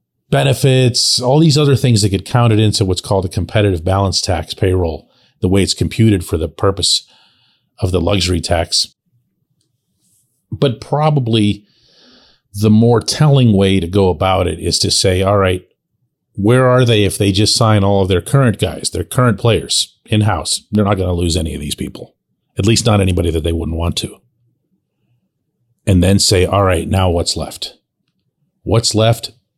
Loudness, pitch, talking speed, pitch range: -14 LUFS, 100 Hz, 175 wpm, 90-115 Hz